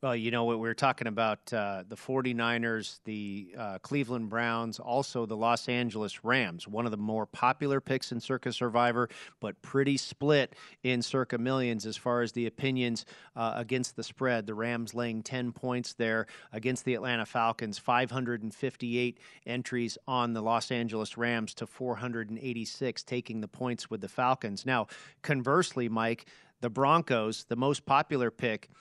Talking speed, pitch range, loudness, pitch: 160 wpm, 115-130 Hz, -32 LUFS, 120 Hz